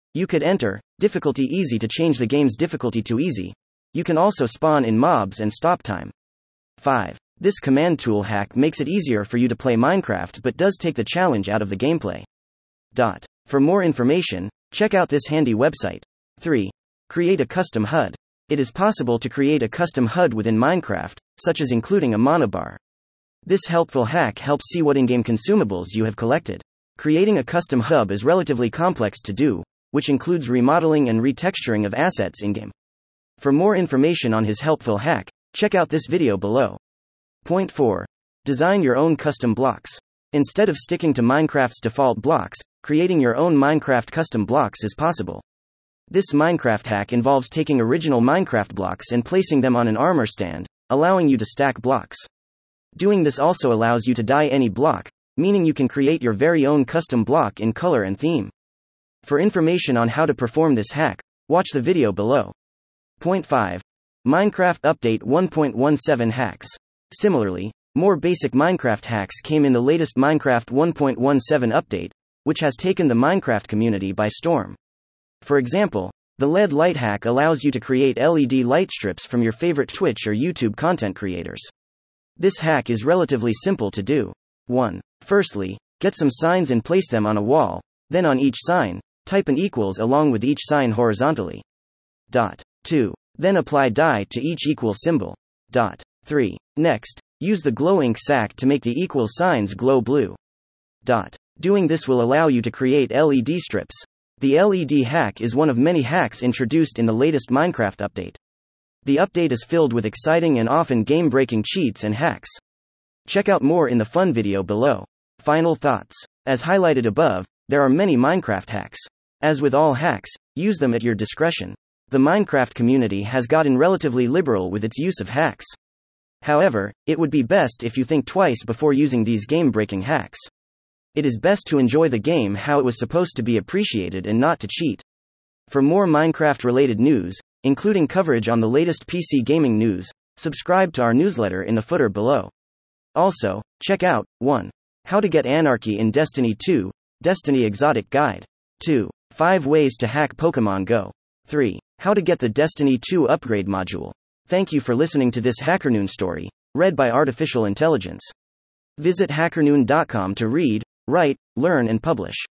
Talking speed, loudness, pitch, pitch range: 175 wpm, -20 LUFS, 130 Hz, 110-160 Hz